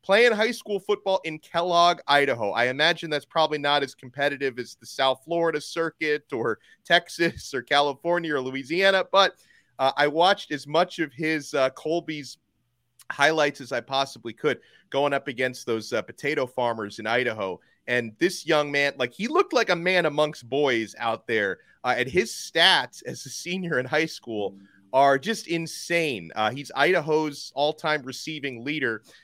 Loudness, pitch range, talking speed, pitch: -24 LUFS, 130-170 Hz, 170 wpm, 150 Hz